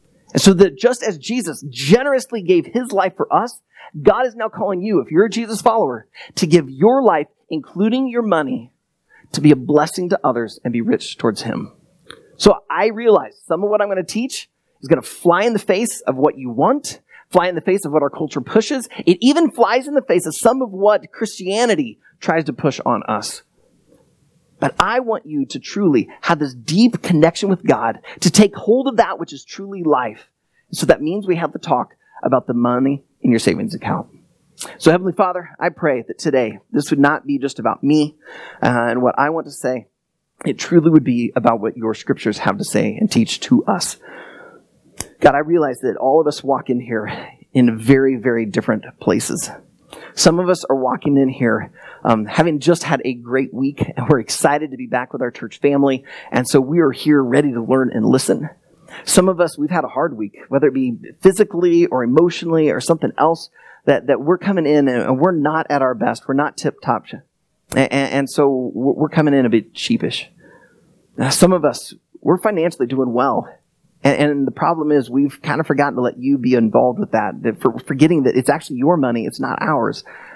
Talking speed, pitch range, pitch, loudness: 215 wpm, 135-200 Hz, 160 Hz, -17 LUFS